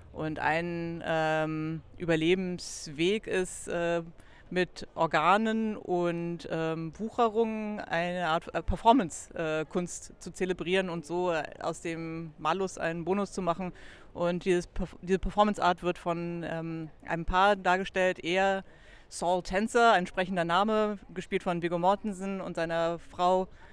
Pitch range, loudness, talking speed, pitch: 165-190 Hz, -30 LUFS, 125 wpm, 180 Hz